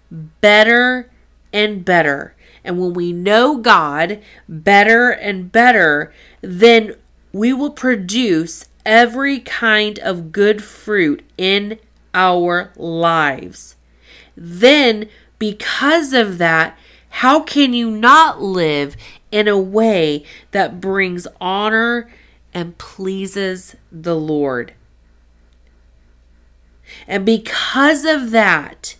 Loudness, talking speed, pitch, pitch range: -14 LUFS, 95 wpm, 200 Hz, 165-230 Hz